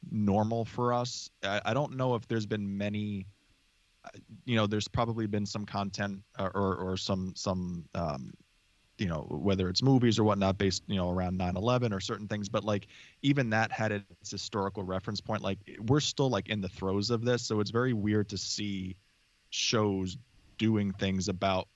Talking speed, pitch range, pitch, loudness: 180 wpm, 95-110 Hz, 105 Hz, -31 LUFS